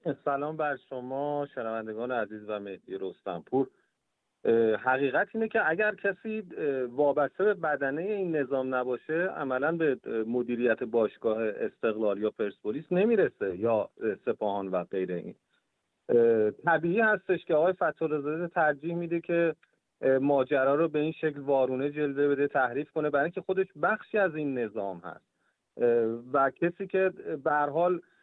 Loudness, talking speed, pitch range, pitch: -29 LUFS, 135 wpm, 120-170 Hz, 145 Hz